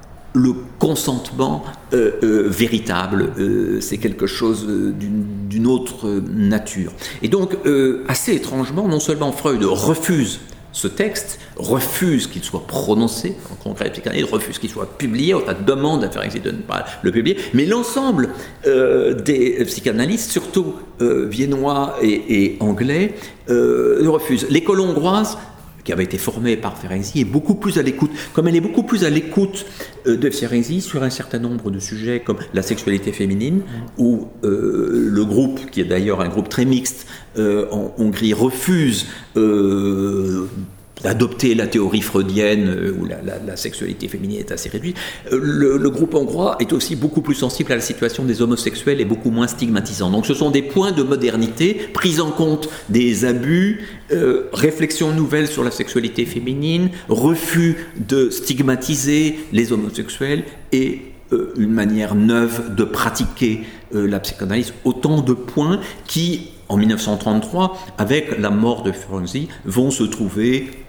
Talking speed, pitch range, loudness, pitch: 160 wpm, 105-155 Hz, -19 LUFS, 125 Hz